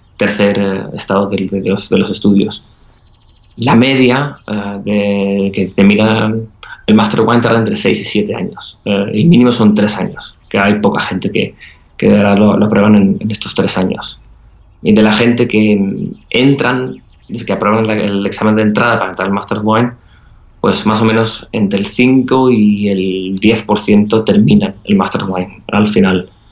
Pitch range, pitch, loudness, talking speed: 100-110 Hz, 105 Hz, -12 LUFS, 175 wpm